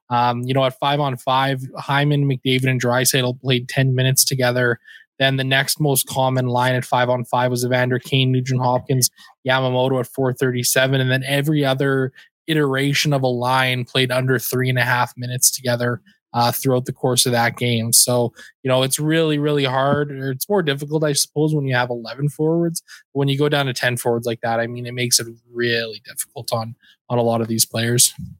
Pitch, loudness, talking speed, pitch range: 130 Hz, -19 LUFS, 210 wpm, 125-140 Hz